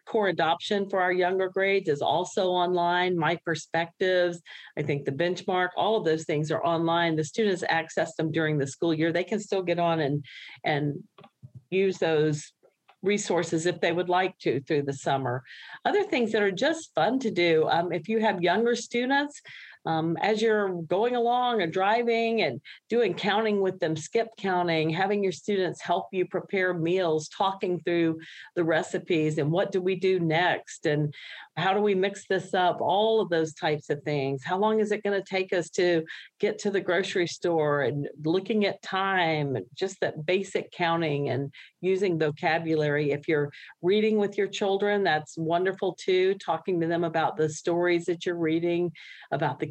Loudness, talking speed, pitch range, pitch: -27 LUFS, 180 wpm, 160-195 Hz, 175 Hz